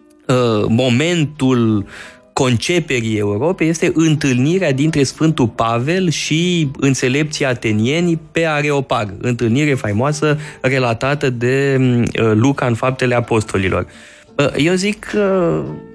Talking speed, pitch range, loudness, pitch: 90 wpm, 120-155 Hz, -16 LUFS, 135 Hz